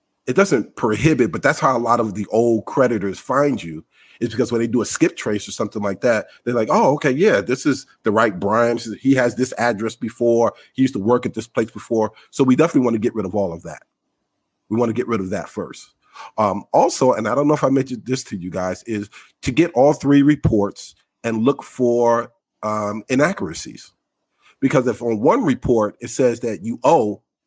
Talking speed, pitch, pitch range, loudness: 225 wpm, 120 Hz, 110-130 Hz, -19 LUFS